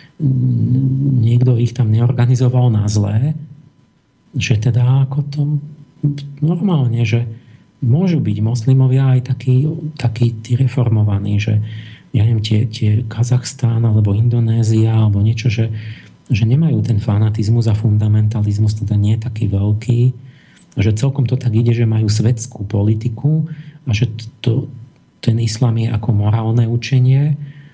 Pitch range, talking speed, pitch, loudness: 110-130 Hz, 125 wpm, 120 Hz, -16 LUFS